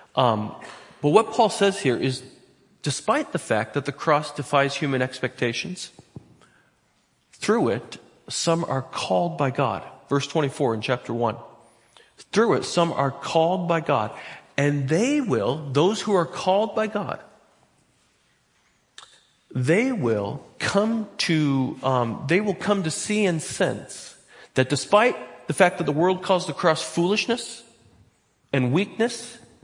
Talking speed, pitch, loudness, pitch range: 140 wpm, 155 Hz, -23 LUFS, 130-195 Hz